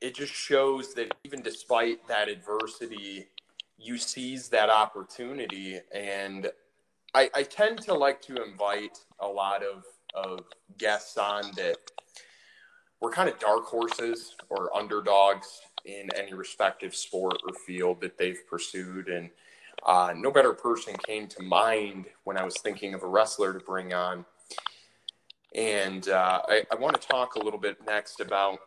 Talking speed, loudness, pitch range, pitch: 155 wpm, -29 LUFS, 95-115 Hz, 100 Hz